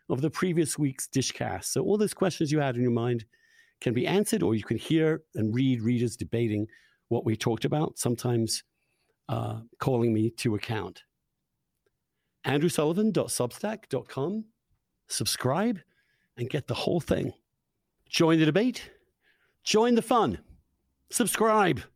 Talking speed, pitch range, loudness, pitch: 135 wpm, 120-185 Hz, -28 LUFS, 140 Hz